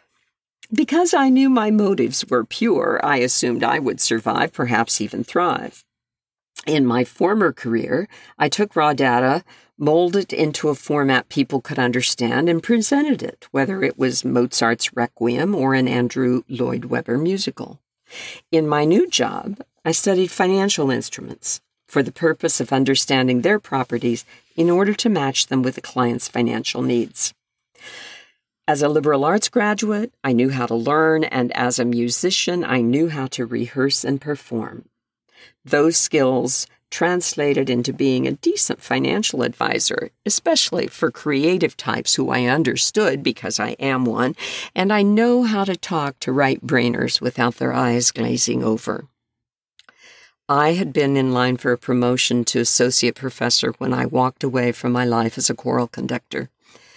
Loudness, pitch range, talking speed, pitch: -19 LUFS, 125-165 Hz, 155 wpm, 135 Hz